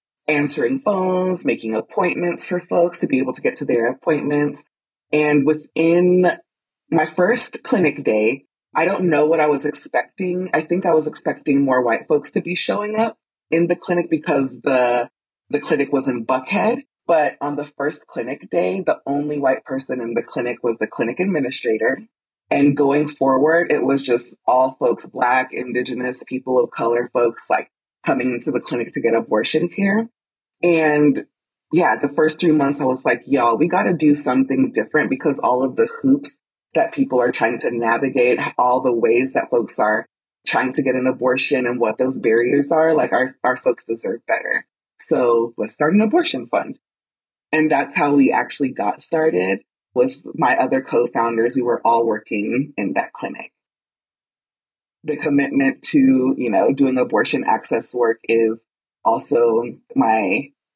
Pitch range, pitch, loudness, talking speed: 125-170 Hz, 145 Hz, -19 LUFS, 170 wpm